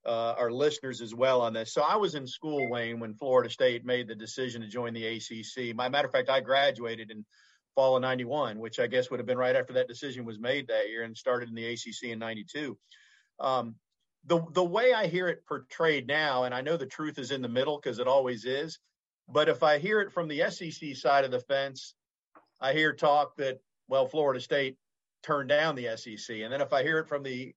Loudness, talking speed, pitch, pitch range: -30 LUFS, 235 wpm, 130 Hz, 115-150 Hz